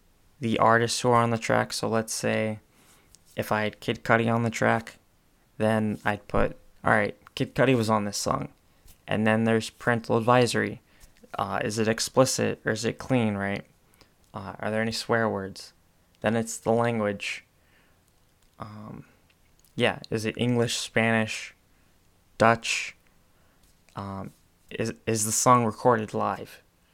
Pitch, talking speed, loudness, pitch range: 110 Hz, 145 wpm, -26 LUFS, 95-115 Hz